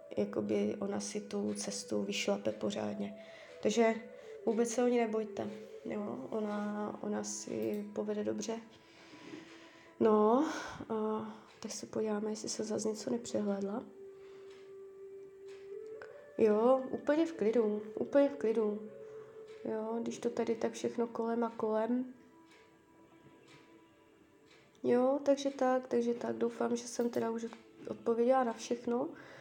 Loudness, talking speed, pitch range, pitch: -35 LUFS, 120 wpm, 210-260 Hz, 230 Hz